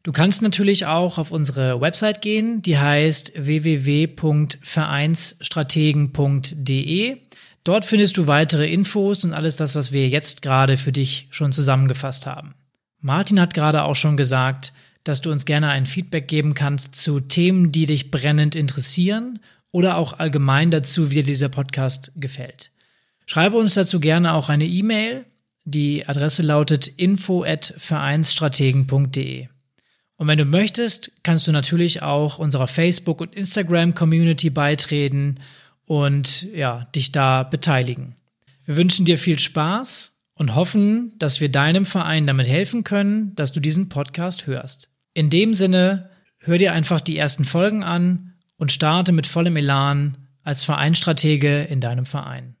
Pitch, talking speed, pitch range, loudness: 155 Hz, 145 wpm, 140-175 Hz, -19 LUFS